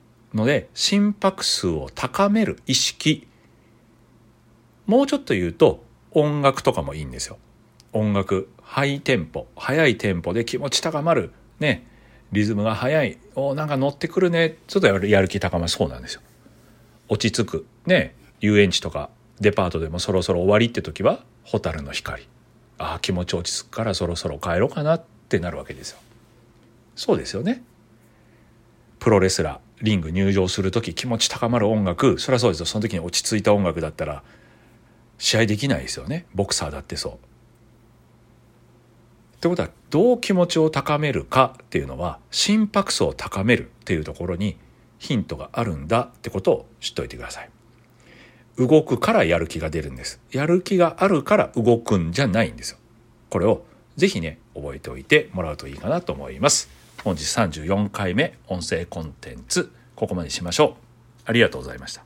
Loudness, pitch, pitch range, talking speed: -22 LUFS, 115 Hz, 100-135 Hz, 280 characters per minute